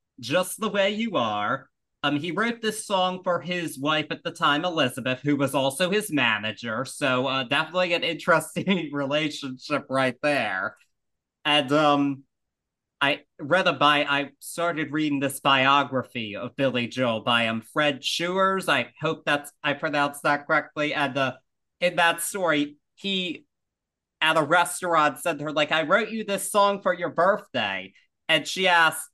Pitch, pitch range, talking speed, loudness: 155 Hz, 140-180 Hz, 165 wpm, -24 LUFS